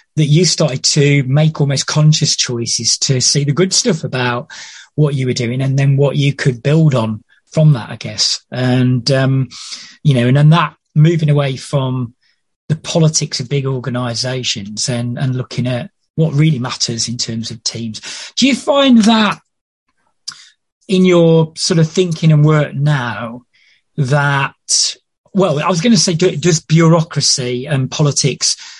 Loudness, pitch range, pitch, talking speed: -14 LUFS, 125-160 Hz, 140 Hz, 165 wpm